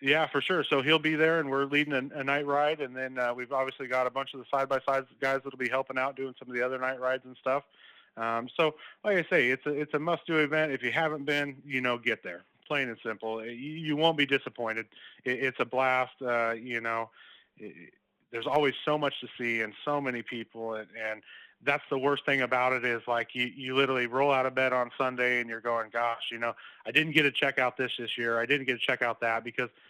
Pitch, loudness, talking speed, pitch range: 130 Hz, -29 LUFS, 260 wpm, 120-140 Hz